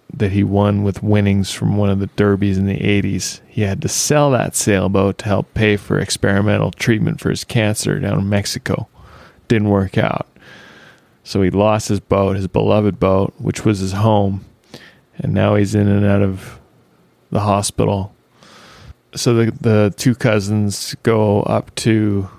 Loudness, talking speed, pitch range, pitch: -17 LUFS, 170 wpm, 100-110 Hz, 100 Hz